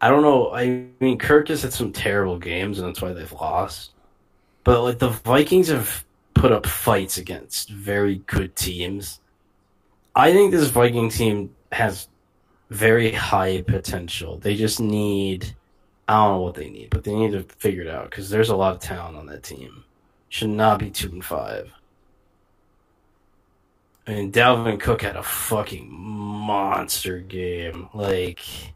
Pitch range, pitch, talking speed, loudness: 95-110 Hz, 100 Hz, 165 wpm, -21 LUFS